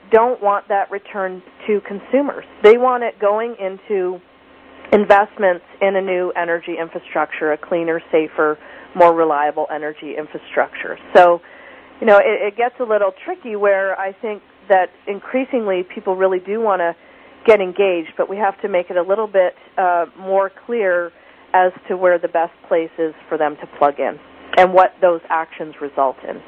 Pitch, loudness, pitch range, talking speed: 190 Hz, -17 LUFS, 170-205 Hz, 170 wpm